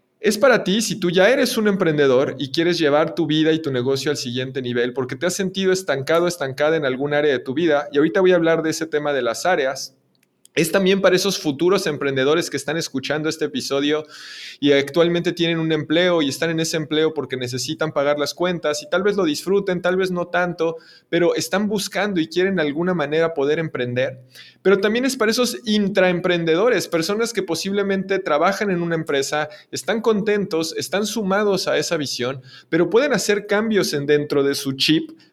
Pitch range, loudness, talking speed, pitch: 145-190 Hz, -20 LUFS, 200 wpm, 165 Hz